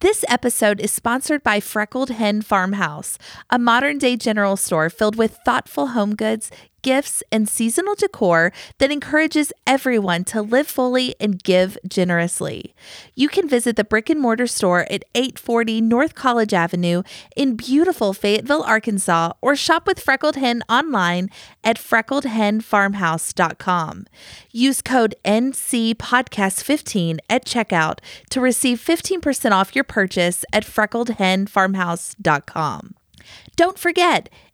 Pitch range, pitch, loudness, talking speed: 200-265 Hz, 230 Hz, -19 LUFS, 125 wpm